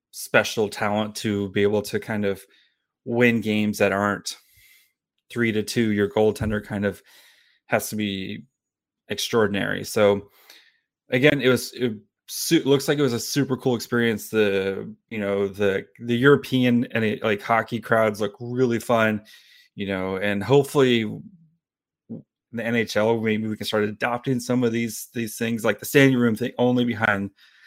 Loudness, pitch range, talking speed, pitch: -23 LUFS, 105-125 Hz, 155 wpm, 115 Hz